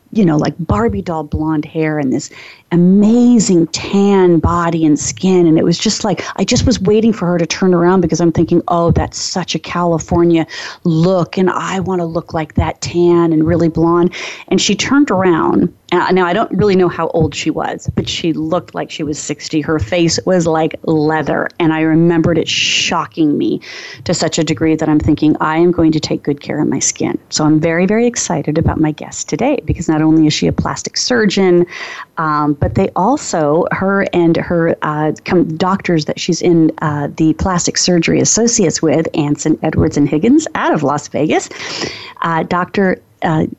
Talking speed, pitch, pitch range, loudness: 195 wpm, 170 Hz, 155-185 Hz, -14 LUFS